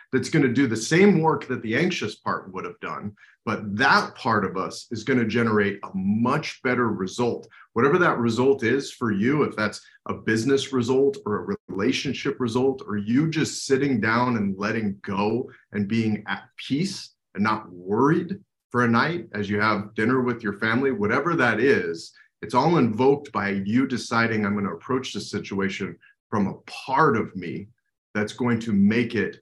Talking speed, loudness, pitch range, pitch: 190 wpm, -24 LUFS, 105-130 Hz, 115 Hz